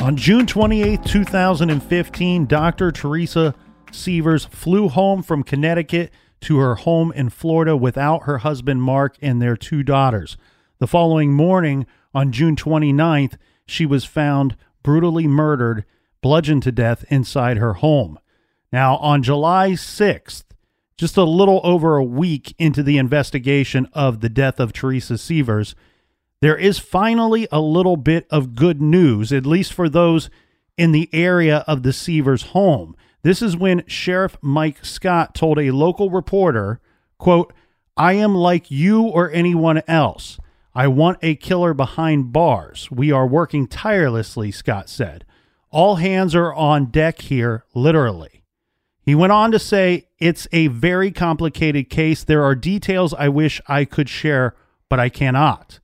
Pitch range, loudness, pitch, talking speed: 135-170 Hz, -17 LUFS, 155 Hz, 150 wpm